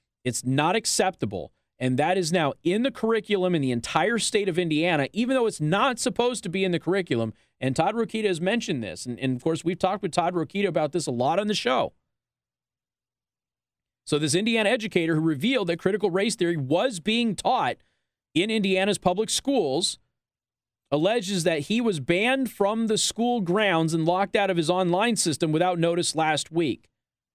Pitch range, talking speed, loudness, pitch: 160-215 Hz, 185 wpm, -24 LUFS, 185 Hz